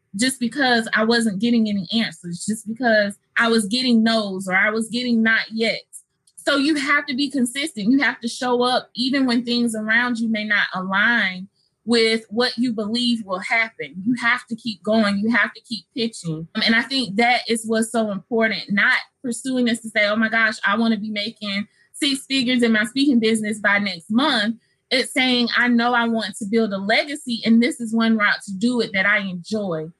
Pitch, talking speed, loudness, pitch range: 225 Hz, 210 wpm, -20 LUFS, 210-240 Hz